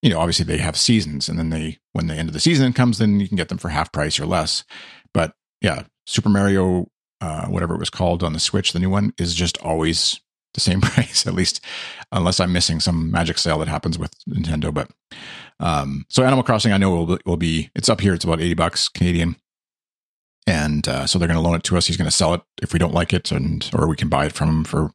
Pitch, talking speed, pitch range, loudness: 85 Hz, 260 wpm, 80-95 Hz, -20 LUFS